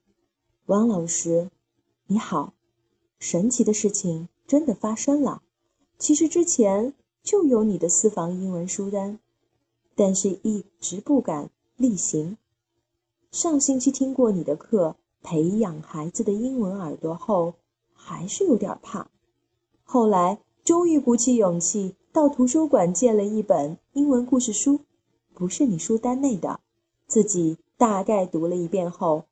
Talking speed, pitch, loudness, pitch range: 200 characters per minute, 205 Hz, -23 LUFS, 170-250 Hz